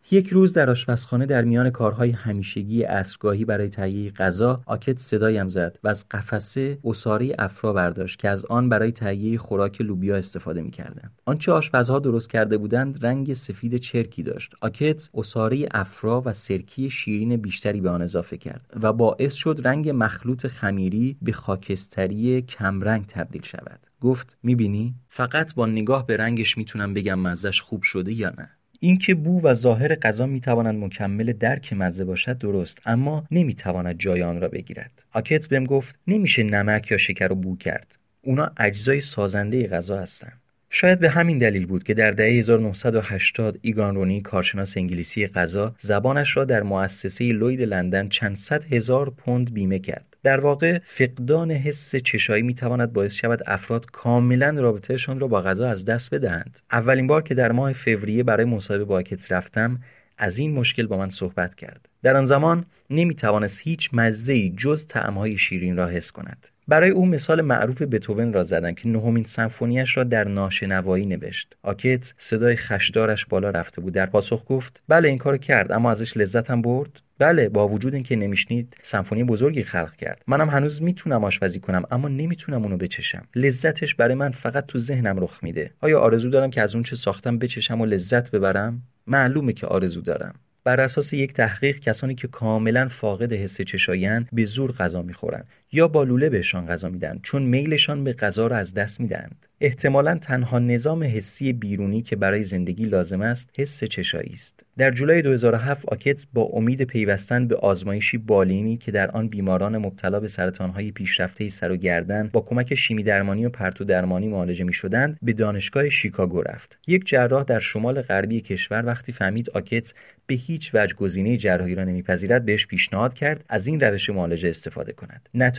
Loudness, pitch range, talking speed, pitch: -22 LUFS, 100-130 Hz, 170 wpm, 115 Hz